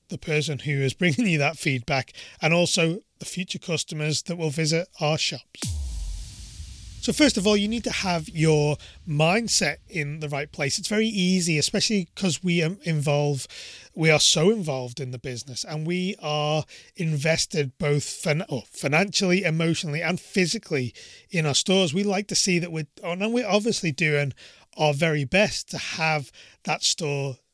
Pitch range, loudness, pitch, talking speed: 145-185 Hz, -24 LUFS, 160 Hz, 170 wpm